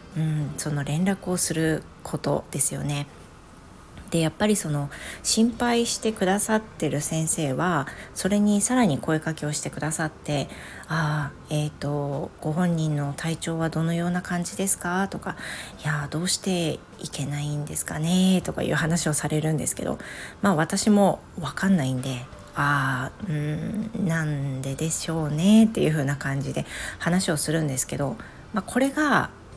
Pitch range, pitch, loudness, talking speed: 145-185 Hz, 160 Hz, -25 LUFS, 315 characters per minute